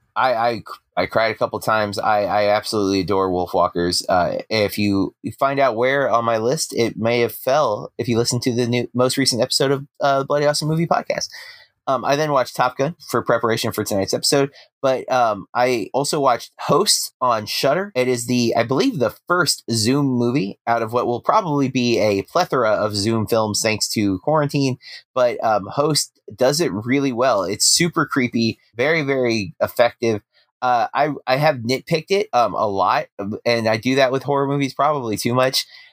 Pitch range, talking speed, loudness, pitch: 110-140 Hz, 195 wpm, -19 LUFS, 125 Hz